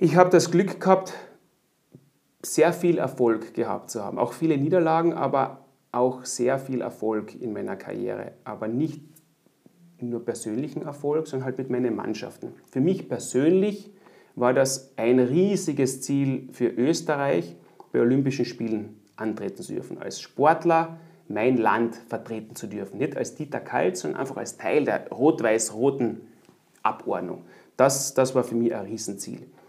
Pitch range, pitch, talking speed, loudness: 120-160 Hz, 135 Hz, 150 wpm, -25 LUFS